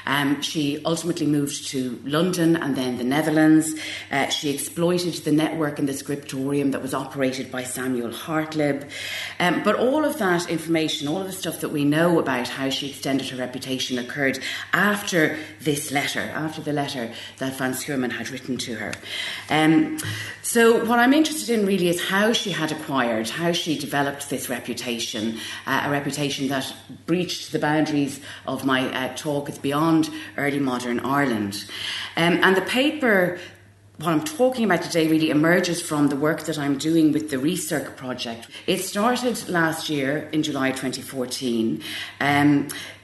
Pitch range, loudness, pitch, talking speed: 130-165 Hz, -23 LUFS, 145 Hz, 165 wpm